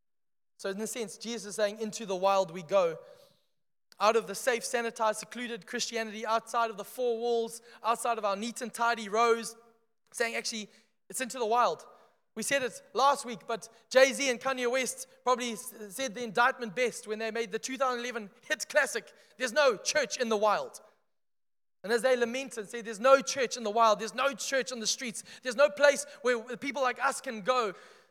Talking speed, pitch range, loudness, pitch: 200 wpm, 220-255 Hz, -30 LUFS, 235 Hz